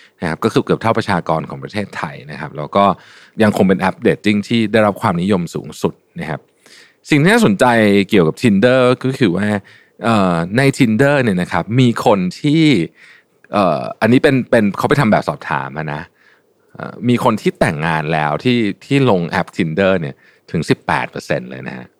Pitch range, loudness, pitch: 90-130 Hz, -15 LUFS, 110 Hz